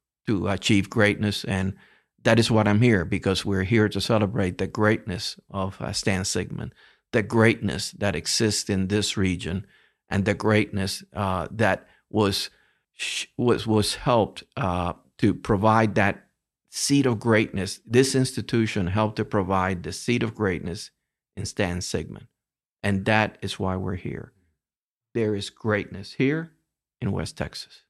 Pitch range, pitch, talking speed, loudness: 95-110 Hz, 105 Hz, 150 wpm, -24 LUFS